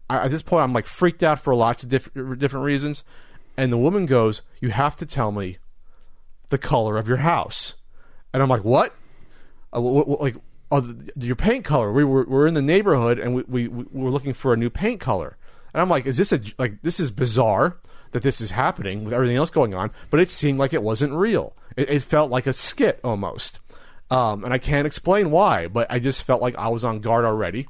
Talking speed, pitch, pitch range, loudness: 230 wpm, 130 Hz, 120-145 Hz, -21 LUFS